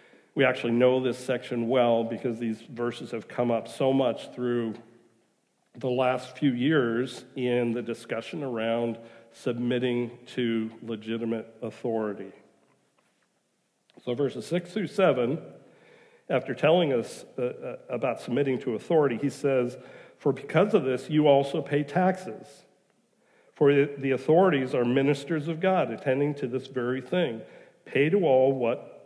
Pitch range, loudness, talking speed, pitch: 115-140 Hz, -27 LUFS, 135 wpm, 125 Hz